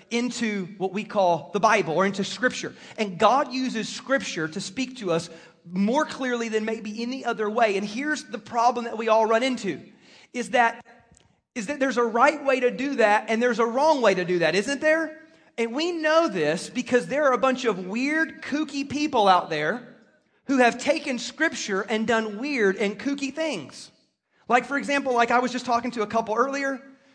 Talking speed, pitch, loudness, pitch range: 200 wpm, 240 Hz, -24 LUFS, 210-270 Hz